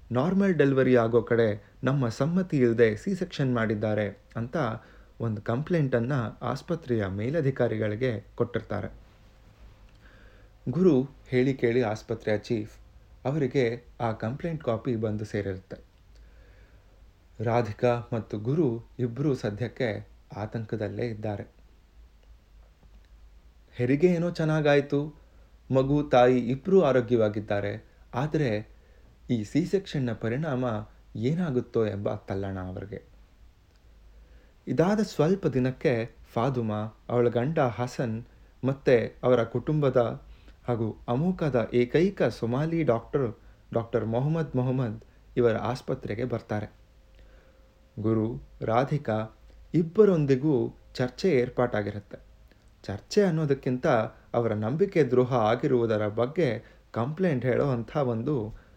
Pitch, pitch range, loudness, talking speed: 120 Hz, 105-130 Hz, -27 LUFS, 90 wpm